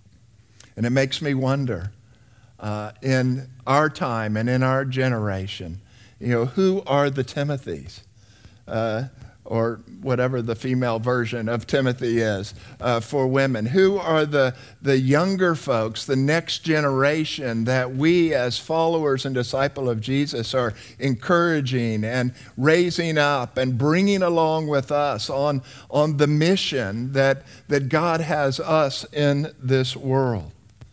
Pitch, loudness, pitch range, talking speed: 130 Hz, -22 LUFS, 115-145 Hz, 135 wpm